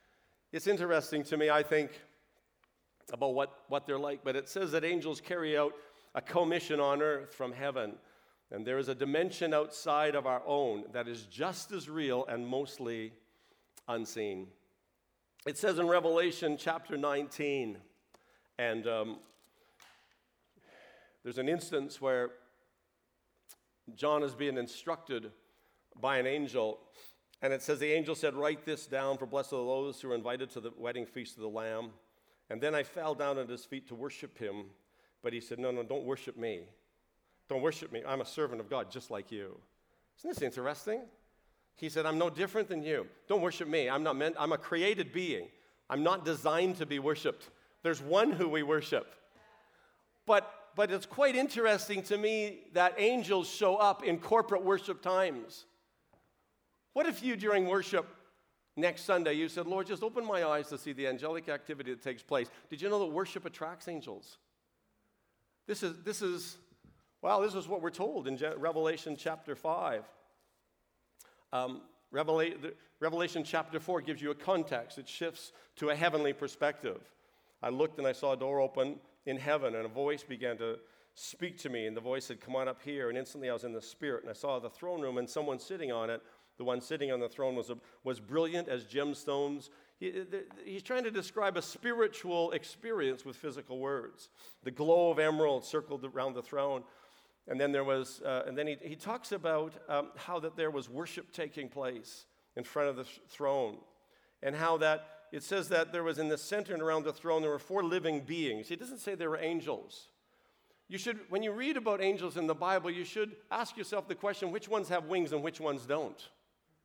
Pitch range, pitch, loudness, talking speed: 135-180 Hz, 155 Hz, -35 LUFS, 190 wpm